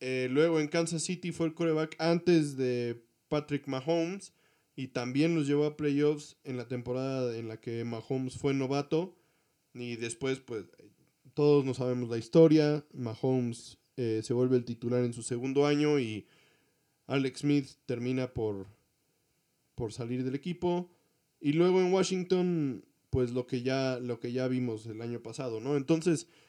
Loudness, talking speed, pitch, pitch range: -31 LUFS, 160 wpm, 135 Hz, 125-155 Hz